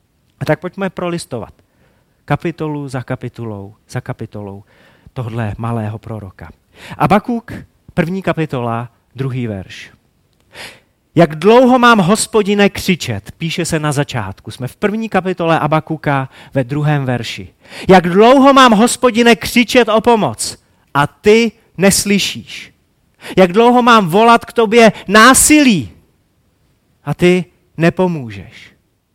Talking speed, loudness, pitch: 110 wpm, -12 LUFS, 160 Hz